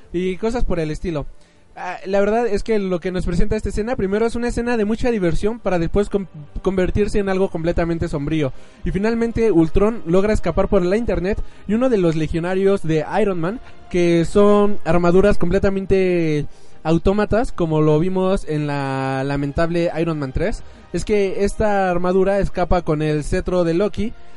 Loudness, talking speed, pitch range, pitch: -19 LUFS, 170 wpm, 170-205 Hz, 185 Hz